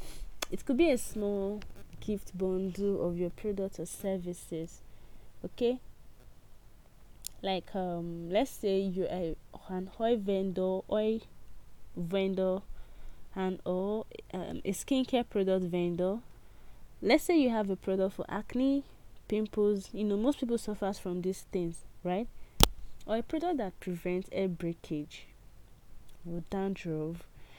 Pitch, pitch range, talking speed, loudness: 190 Hz, 180-215 Hz, 125 wpm, -33 LUFS